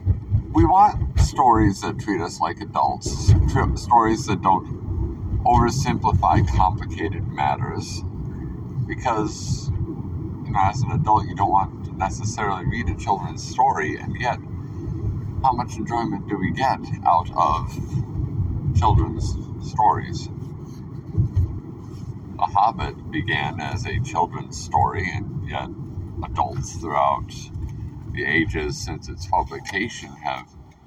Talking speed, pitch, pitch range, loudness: 115 wpm, 105 Hz, 95-115 Hz, -23 LUFS